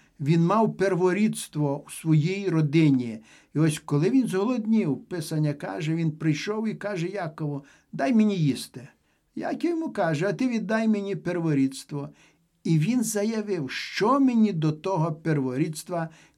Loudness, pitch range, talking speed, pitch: -25 LUFS, 155-215 Hz, 135 wpm, 170 Hz